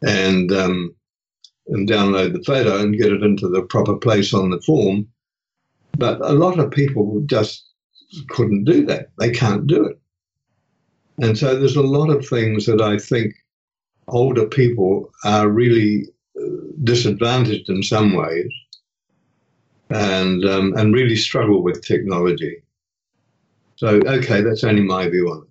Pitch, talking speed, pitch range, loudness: 110 Hz, 145 wpm, 100-125 Hz, -17 LUFS